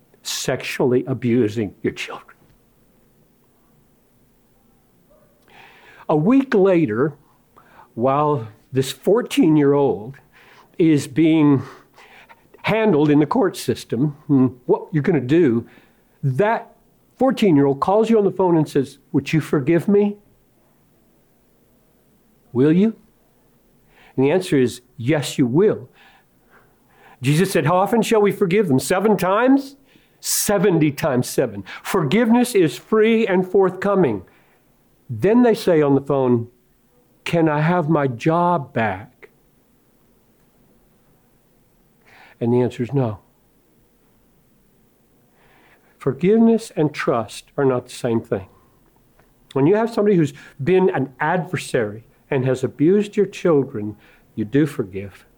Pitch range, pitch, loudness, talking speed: 130-195 Hz, 150 Hz, -19 LUFS, 115 wpm